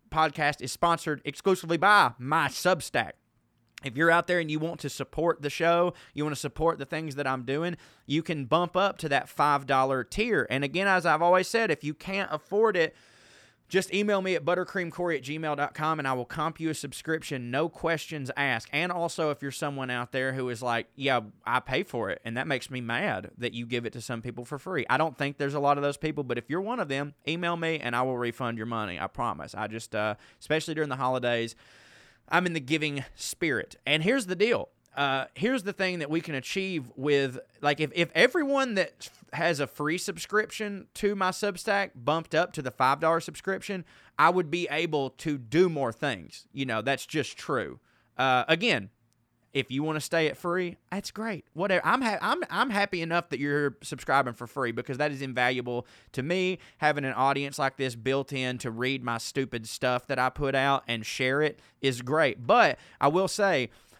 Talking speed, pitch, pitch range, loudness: 215 wpm, 145 Hz, 130-170 Hz, -28 LUFS